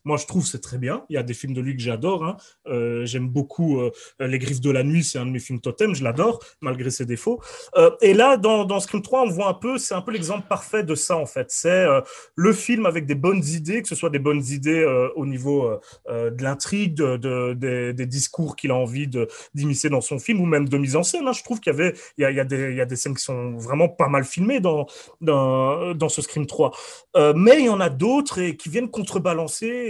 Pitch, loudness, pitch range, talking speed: 150 Hz, -22 LUFS, 130-200 Hz, 255 wpm